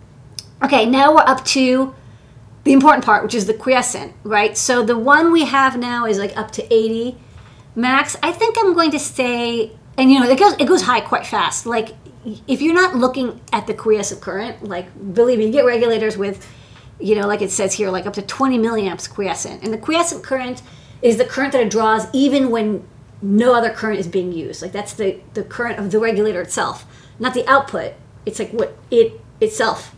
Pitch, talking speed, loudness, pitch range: 230 Hz, 210 wpm, -17 LUFS, 210-265 Hz